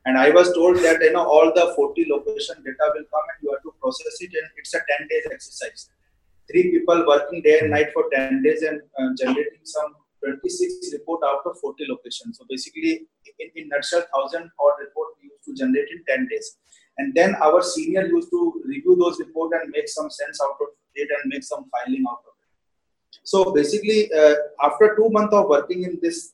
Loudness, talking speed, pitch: -21 LUFS, 205 wpm, 190 Hz